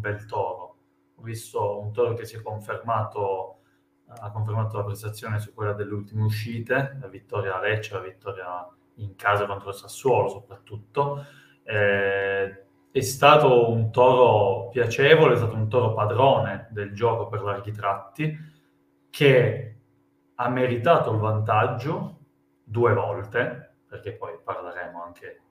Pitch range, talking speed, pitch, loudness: 100-120 Hz, 140 wpm, 105 Hz, -23 LUFS